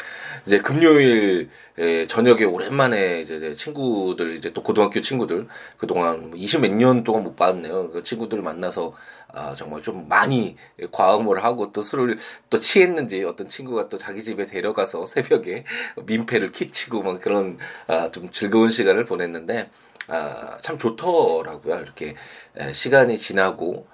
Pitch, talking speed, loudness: 145 Hz, 295 characters per minute, -21 LUFS